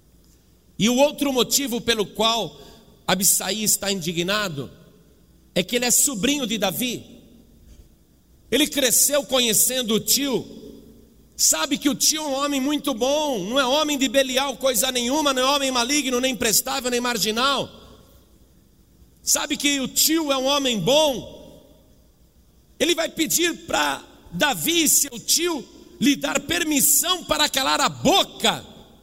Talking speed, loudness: 140 wpm, -20 LUFS